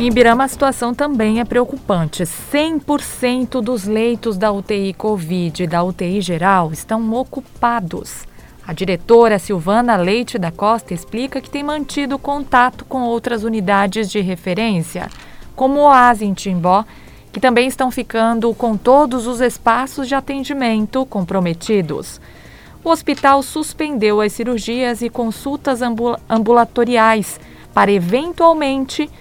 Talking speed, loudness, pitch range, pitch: 125 wpm, -16 LUFS, 205-260 Hz, 235 Hz